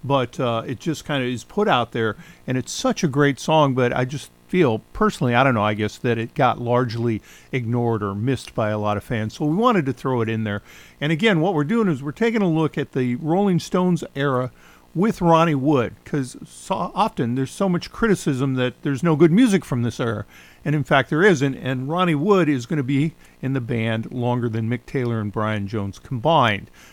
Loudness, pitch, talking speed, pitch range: -21 LUFS, 135 Hz, 225 wpm, 115-160 Hz